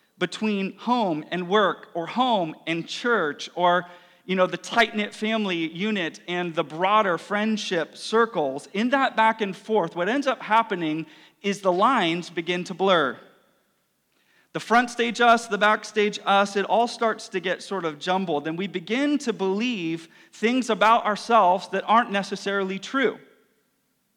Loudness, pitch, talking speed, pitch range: -23 LUFS, 200 Hz, 155 wpm, 175-225 Hz